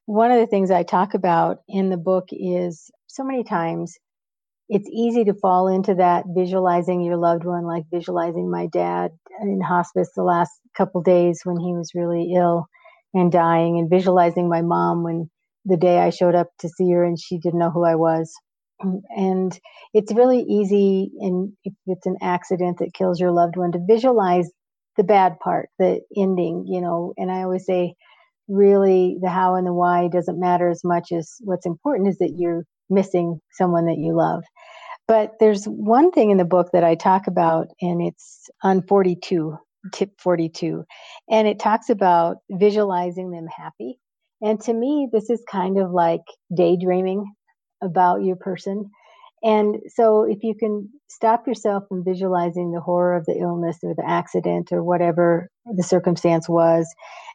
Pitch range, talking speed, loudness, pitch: 175-200 Hz, 175 wpm, -20 LUFS, 180 Hz